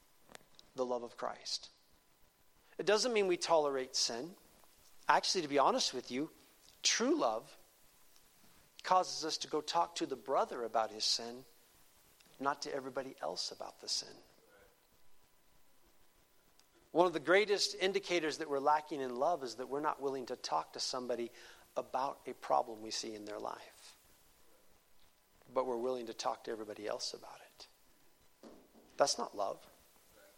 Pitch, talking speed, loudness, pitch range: 135 Hz, 150 wpm, -36 LUFS, 115-165 Hz